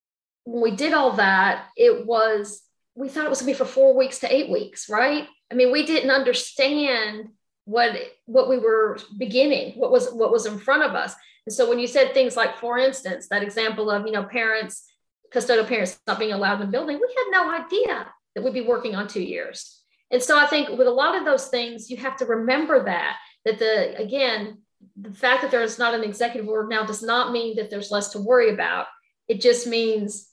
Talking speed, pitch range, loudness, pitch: 220 wpm, 220-275 Hz, -22 LUFS, 245 Hz